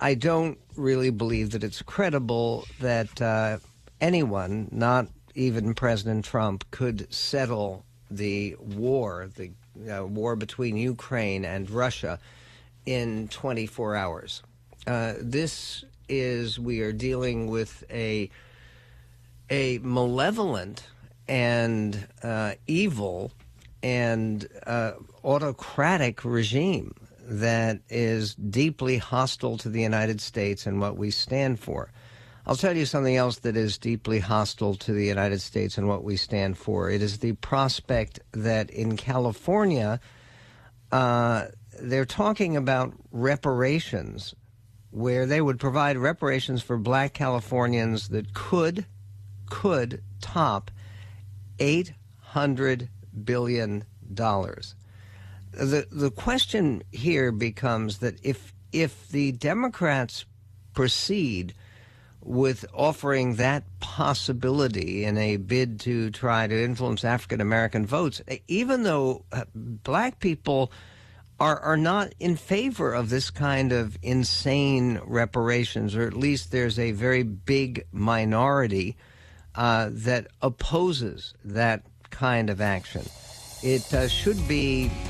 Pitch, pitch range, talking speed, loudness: 115 Hz, 105-130 Hz, 115 wpm, -26 LUFS